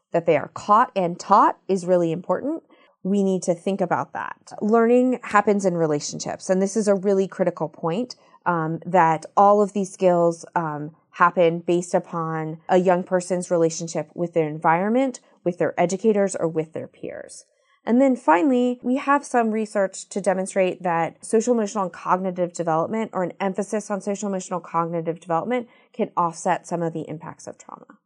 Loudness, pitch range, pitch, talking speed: -22 LUFS, 170-210 Hz, 185 Hz, 175 wpm